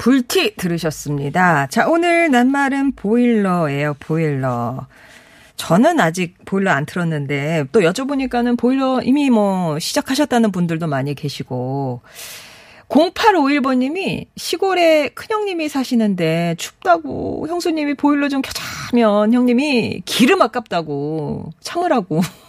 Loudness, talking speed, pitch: -17 LUFS, 270 characters per minute, 225 Hz